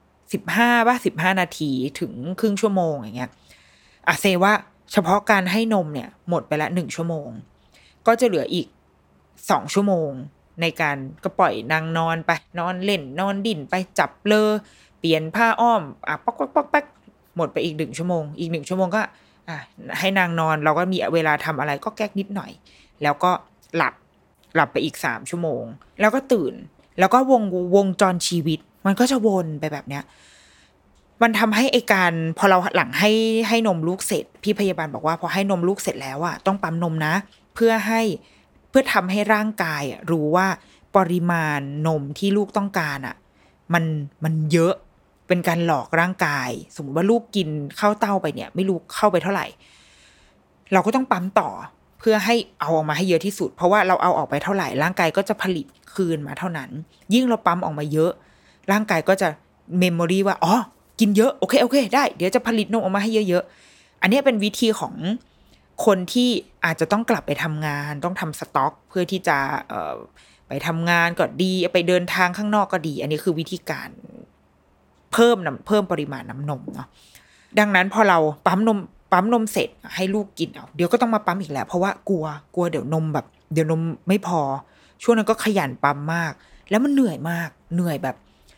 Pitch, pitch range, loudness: 180 Hz, 155-210 Hz, -21 LUFS